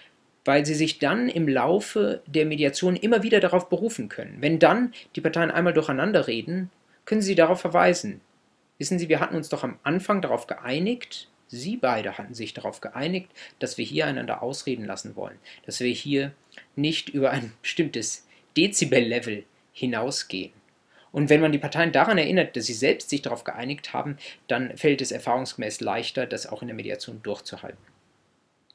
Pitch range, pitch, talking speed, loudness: 140-180 Hz, 155 Hz, 170 wpm, -25 LUFS